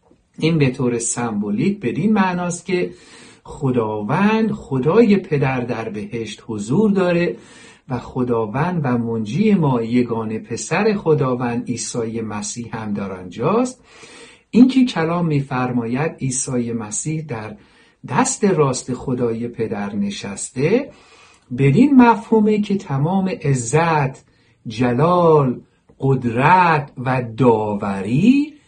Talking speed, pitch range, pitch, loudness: 100 wpm, 120-185 Hz, 135 Hz, -18 LUFS